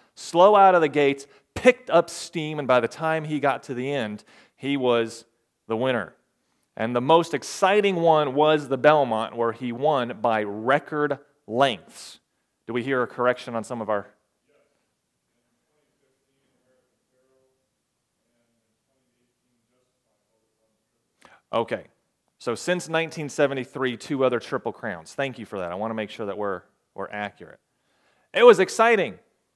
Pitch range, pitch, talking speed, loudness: 115-145 Hz, 130 Hz, 140 wpm, -23 LUFS